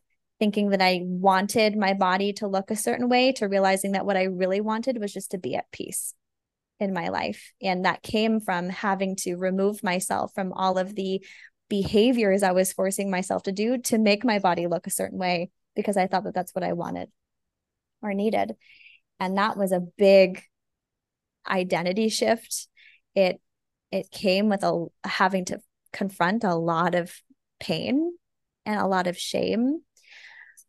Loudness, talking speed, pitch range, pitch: -25 LUFS, 170 wpm, 185-210 Hz, 195 Hz